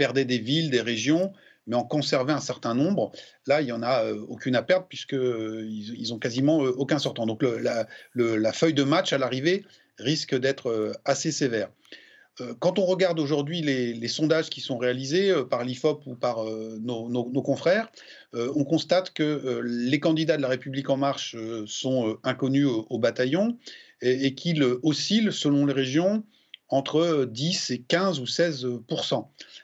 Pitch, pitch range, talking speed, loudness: 135 Hz, 125-160 Hz, 195 wpm, -26 LUFS